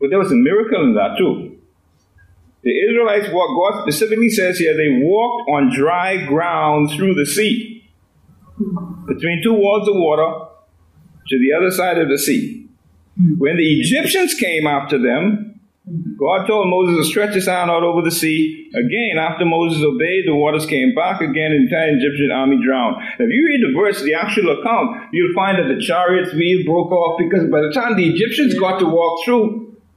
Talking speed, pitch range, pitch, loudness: 190 wpm, 155-220 Hz, 180 Hz, -16 LUFS